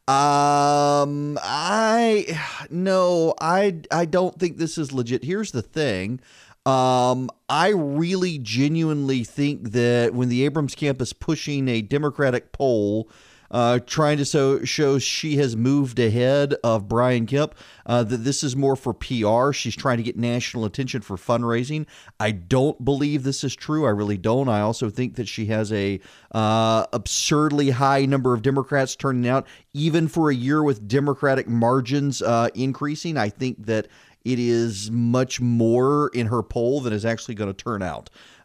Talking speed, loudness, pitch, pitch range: 165 wpm, -22 LUFS, 135 Hz, 120-145 Hz